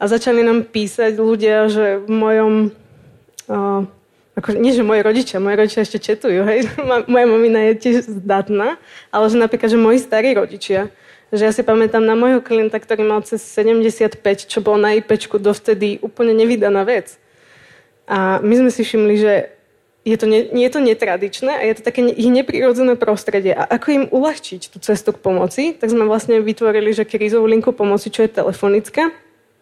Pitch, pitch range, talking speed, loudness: 220 Hz, 210-230 Hz, 180 wpm, -15 LUFS